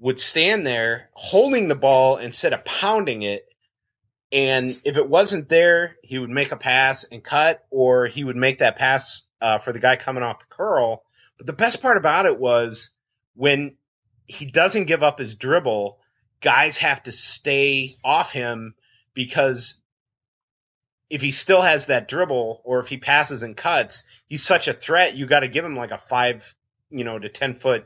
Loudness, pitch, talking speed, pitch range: -20 LUFS, 130 Hz, 185 wpm, 120-145 Hz